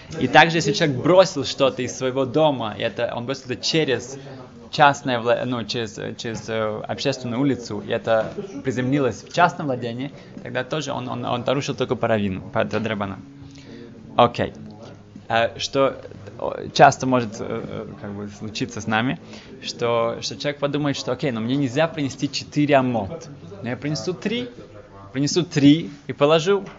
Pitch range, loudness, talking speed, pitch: 115-140 Hz, -22 LUFS, 150 wpm, 130 Hz